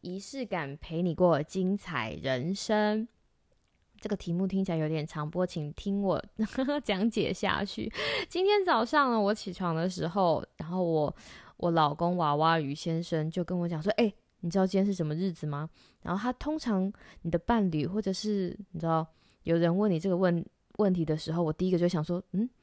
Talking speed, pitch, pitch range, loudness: 275 characters per minute, 180 Hz, 165-205 Hz, -30 LUFS